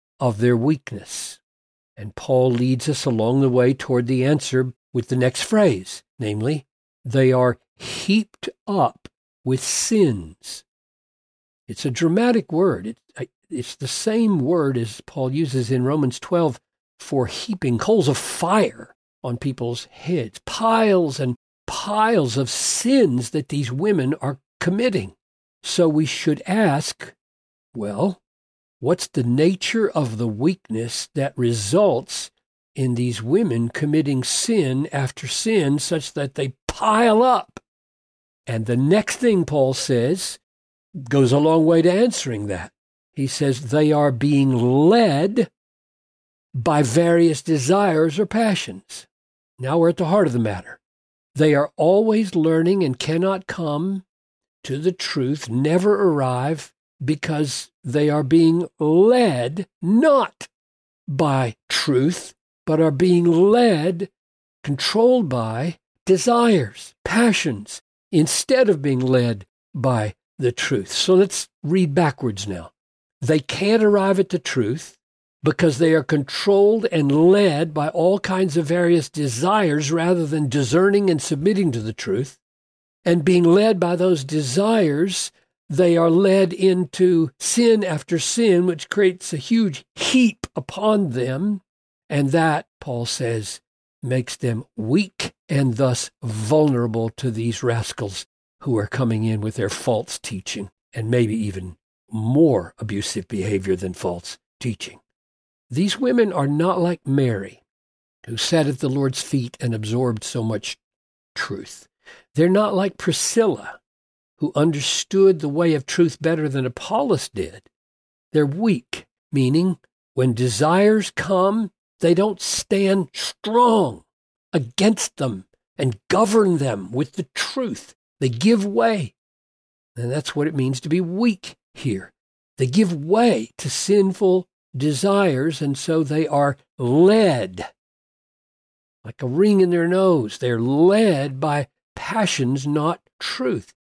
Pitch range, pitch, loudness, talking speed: 125-185 Hz, 150 Hz, -20 LUFS, 130 wpm